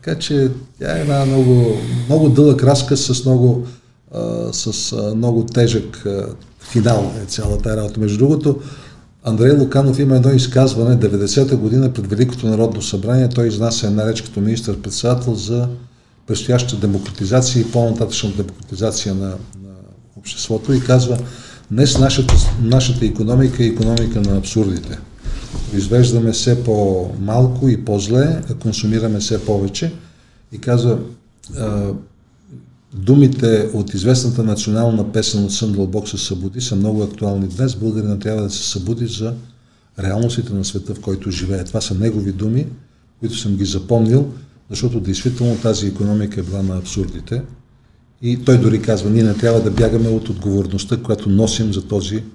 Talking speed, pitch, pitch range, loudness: 145 wpm, 115 Hz, 105-125 Hz, -16 LUFS